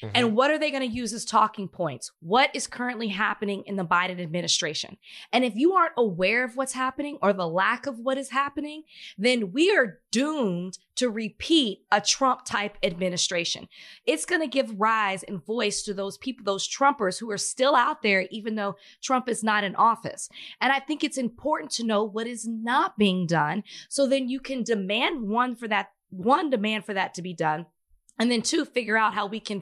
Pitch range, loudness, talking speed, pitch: 200-260 Hz, -25 LUFS, 205 wpm, 225 Hz